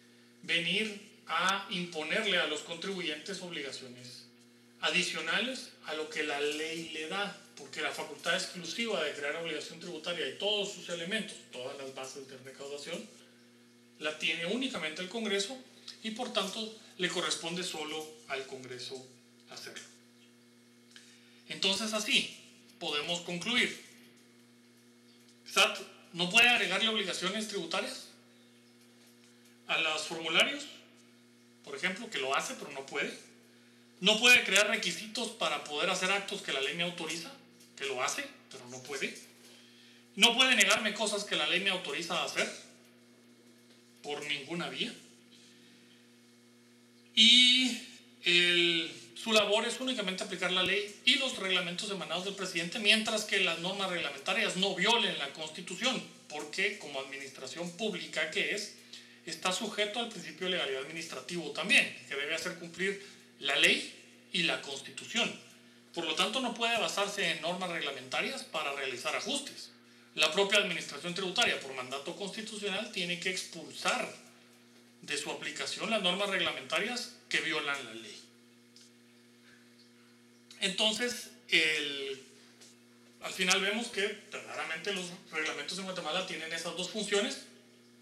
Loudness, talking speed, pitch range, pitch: -31 LUFS, 130 wpm, 120-195 Hz, 160 Hz